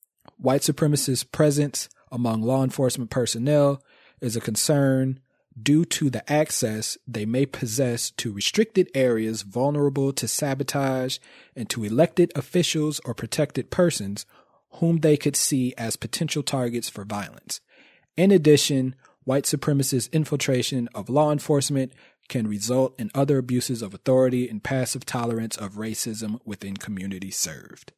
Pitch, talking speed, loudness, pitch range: 130 Hz, 135 wpm, -24 LUFS, 115-145 Hz